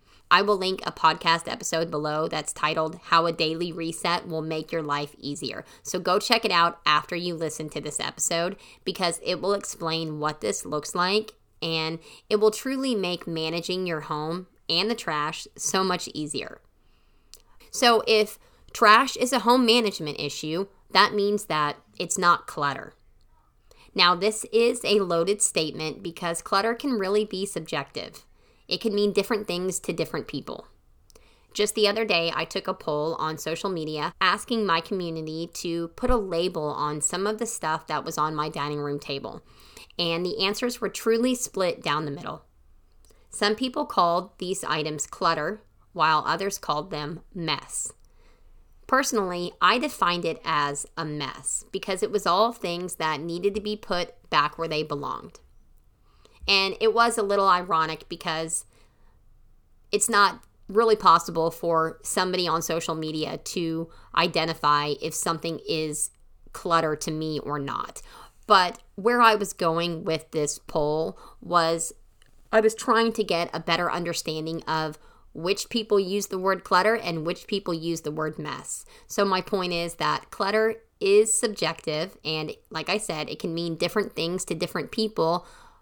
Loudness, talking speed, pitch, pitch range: -25 LUFS, 165 wpm, 170 Hz, 155-205 Hz